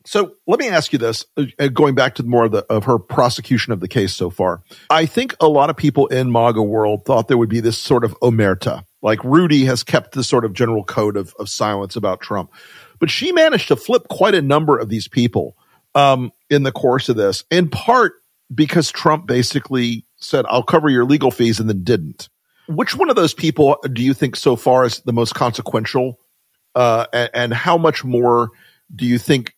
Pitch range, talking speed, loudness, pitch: 115-150 Hz, 215 wpm, -16 LUFS, 125 Hz